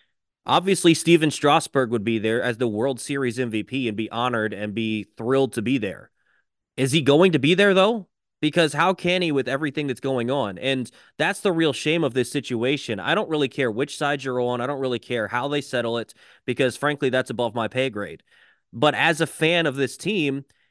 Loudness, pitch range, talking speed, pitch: -22 LUFS, 120-150 Hz, 215 wpm, 135 Hz